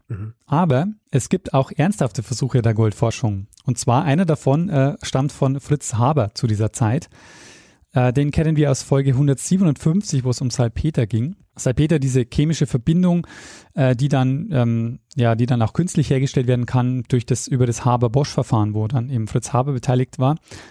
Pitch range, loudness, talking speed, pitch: 120-145 Hz, -20 LUFS, 175 wpm, 130 Hz